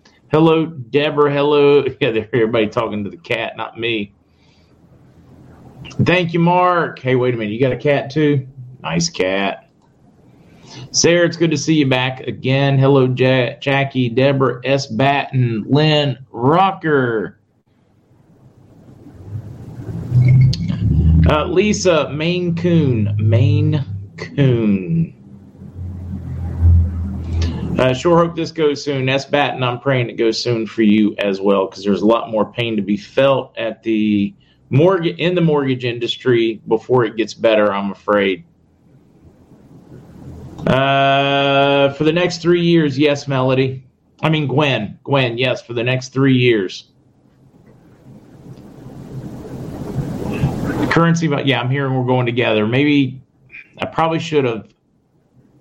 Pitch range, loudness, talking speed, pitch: 110-145 Hz, -16 LUFS, 130 wpm, 130 Hz